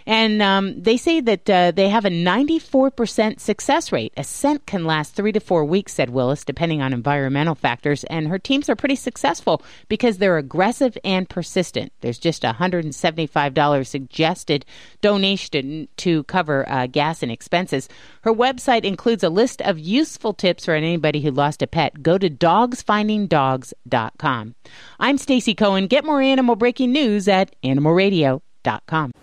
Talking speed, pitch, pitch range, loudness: 155 wpm, 185 Hz, 150-225 Hz, -19 LUFS